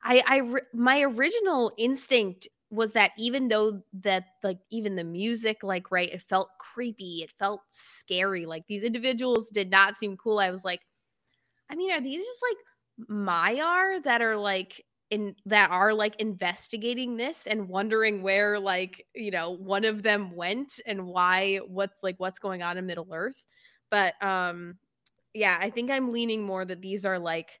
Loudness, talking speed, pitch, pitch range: -27 LUFS, 175 wpm, 205 Hz, 190-235 Hz